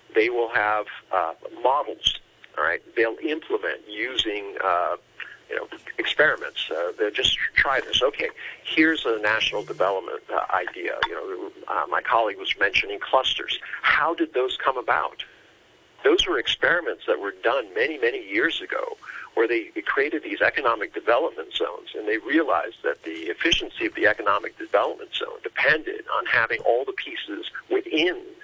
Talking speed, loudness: 160 wpm, -24 LUFS